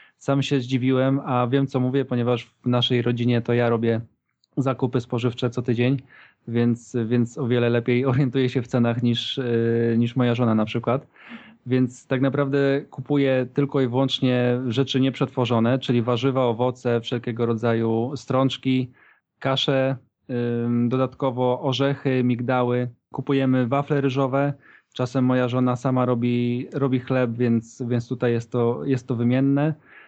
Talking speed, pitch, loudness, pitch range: 140 wpm, 125 Hz, -23 LUFS, 120-135 Hz